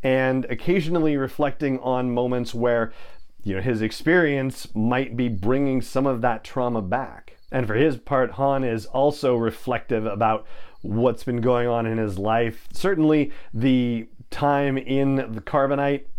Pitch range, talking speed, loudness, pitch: 115-140 Hz, 150 wpm, -23 LUFS, 125 Hz